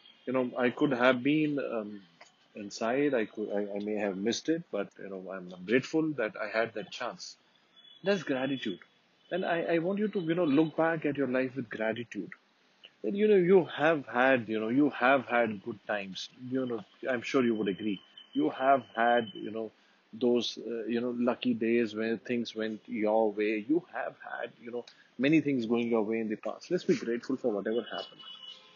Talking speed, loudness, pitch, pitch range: 205 wpm, -31 LUFS, 120 Hz, 110-140 Hz